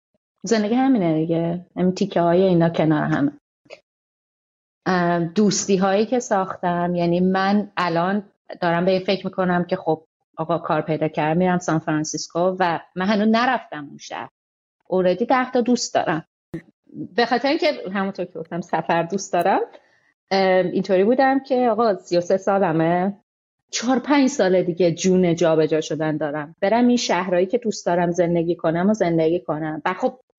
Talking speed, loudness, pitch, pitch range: 155 wpm, -20 LUFS, 185 Hz, 170-210 Hz